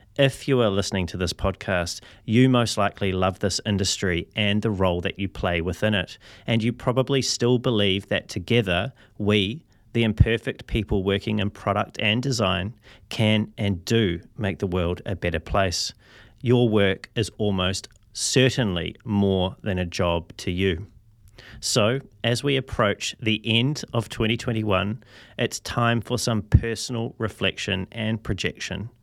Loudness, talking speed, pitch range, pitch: -24 LUFS, 150 wpm, 95-115 Hz, 105 Hz